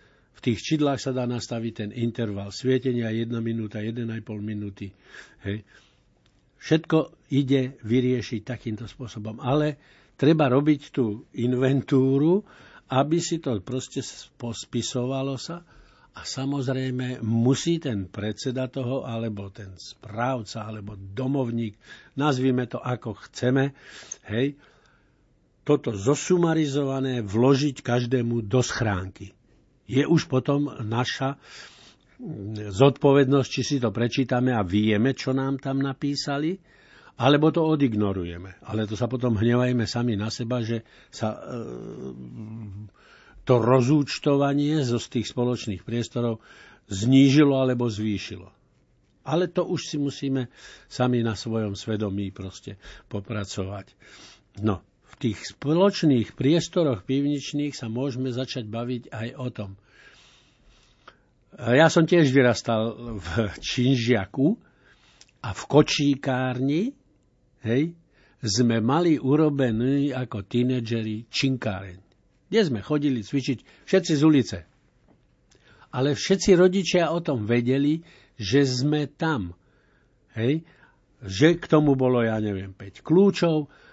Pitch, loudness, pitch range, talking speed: 125 Hz, -24 LUFS, 110-140 Hz, 110 wpm